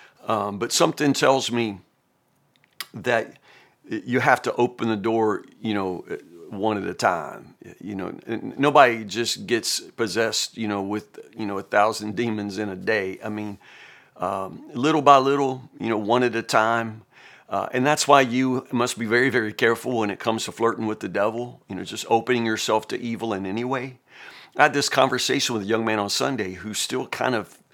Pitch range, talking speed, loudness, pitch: 105-125 Hz, 195 wpm, -23 LUFS, 115 Hz